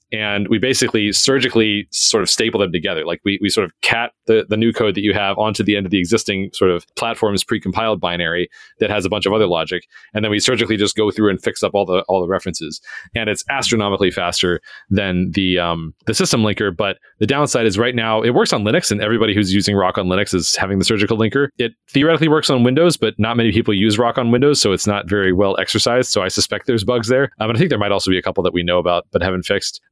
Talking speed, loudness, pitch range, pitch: 260 wpm, -17 LUFS, 95-115 Hz, 105 Hz